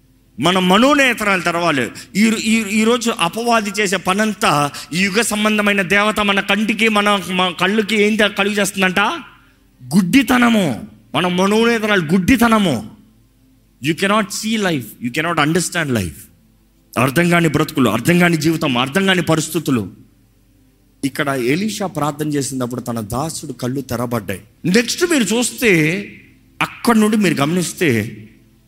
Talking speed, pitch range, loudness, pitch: 115 wpm, 130-210 Hz, -16 LUFS, 175 Hz